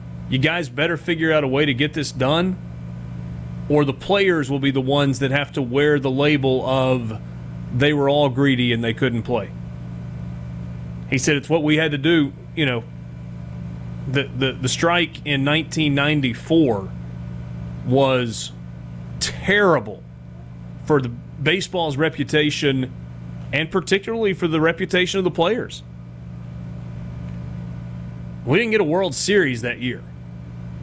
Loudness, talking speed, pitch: -20 LUFS, 140 wpm, 130 Hz